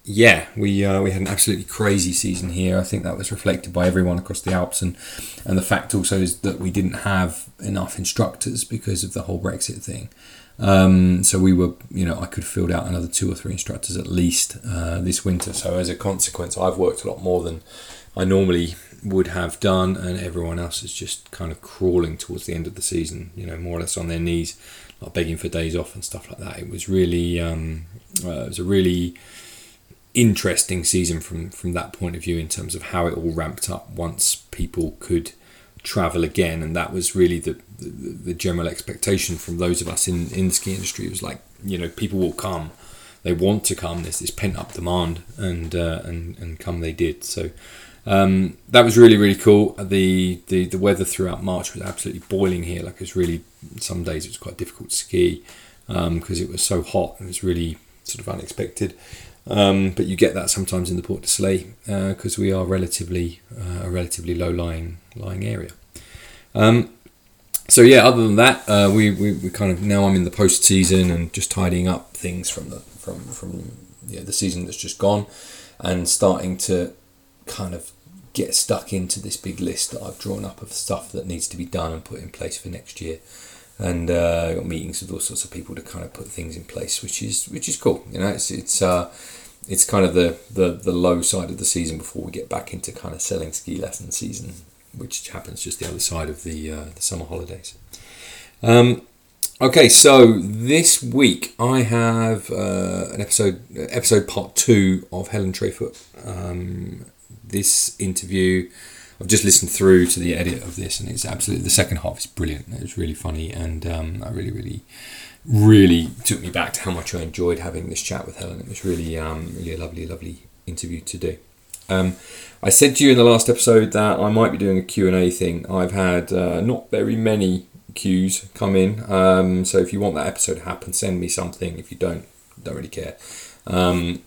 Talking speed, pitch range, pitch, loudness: 215 wpm, 85-100 Hz, 95 Hz, -20 LUFS